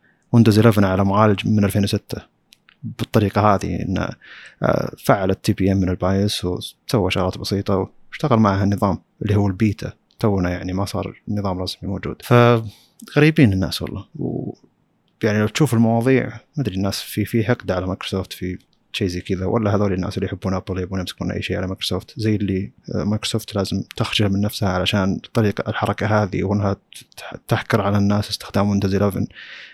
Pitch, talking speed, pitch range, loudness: 100 Hz, 165 wpm, 95-110 Hz, -20 LUFS